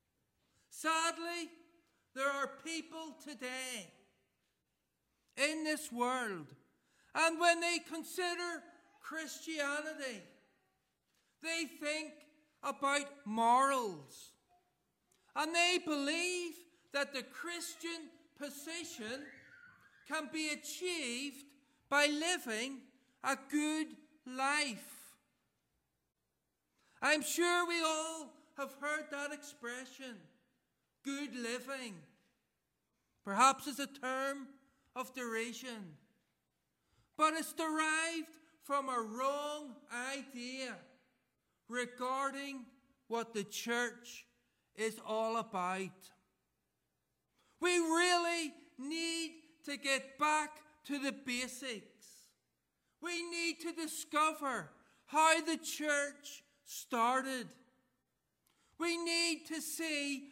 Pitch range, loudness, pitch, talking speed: 255-320 Hz, -37 LUFS, 285 Hz, 85 wpm